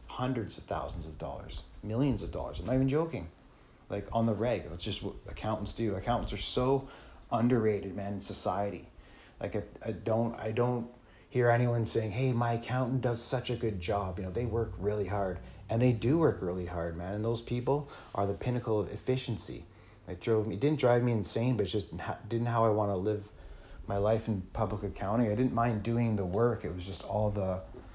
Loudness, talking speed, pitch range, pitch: -32 LUFS, 215 wpm, 100-120 Hz, 110 Hz